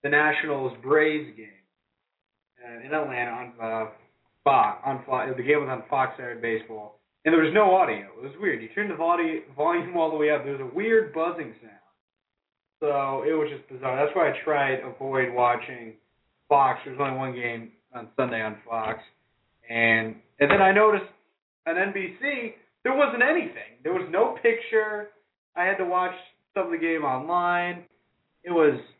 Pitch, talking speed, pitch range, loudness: 145 Hz, 180 wpm, 120-175 Hz, -25 LUFS